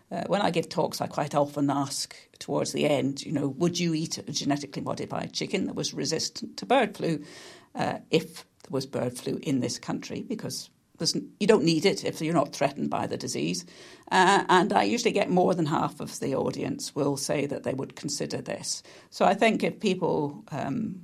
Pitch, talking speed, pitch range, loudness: 160 Hz, 205 wpm, 140-185 Hz, -27 LUFS